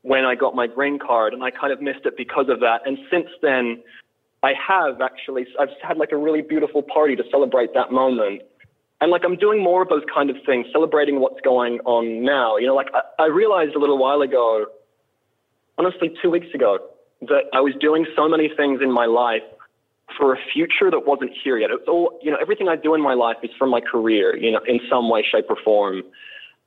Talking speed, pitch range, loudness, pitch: 225 wpm, 130-175 Hz, -19 LUFS, 145 Hz